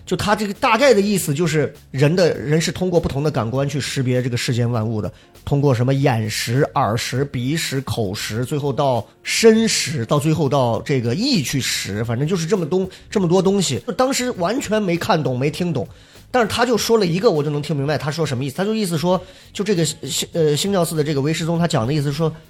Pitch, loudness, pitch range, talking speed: 155 Hz, -19 LUFS, 135-185 Hz, 330 characters per minute